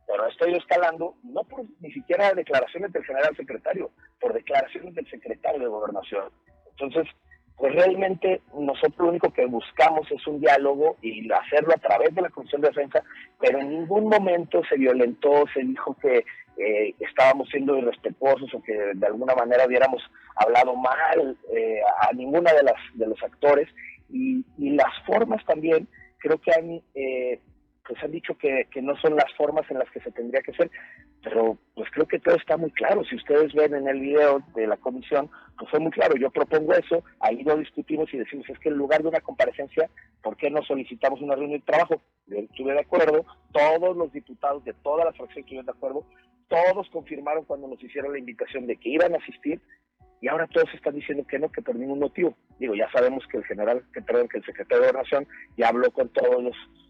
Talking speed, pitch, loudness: 200 wpm, 155 Hz, -24 LUFS